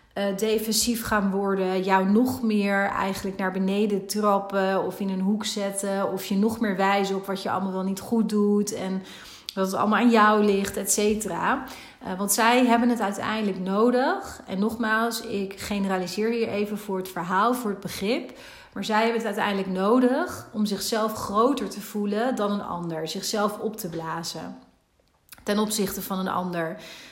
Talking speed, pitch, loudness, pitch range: 175 wpm, 205 Hz, -25 LUFS, 195-220 Hz